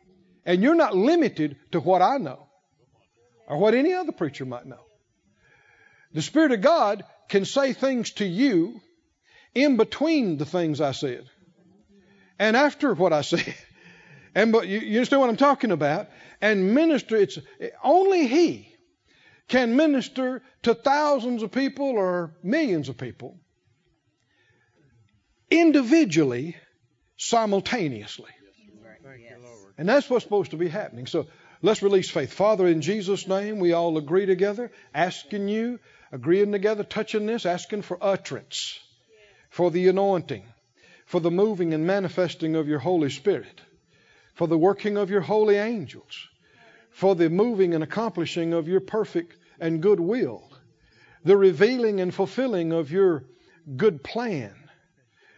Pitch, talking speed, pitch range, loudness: 195 Hz, 140 wpm, 165-235 Hz, -23 LUFS